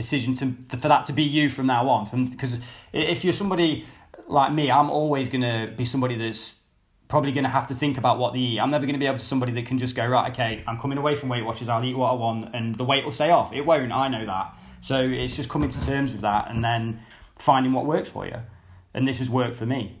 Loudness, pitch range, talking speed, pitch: -24 LUFS, 115-140 Hz, 265 wpm, 130 Hz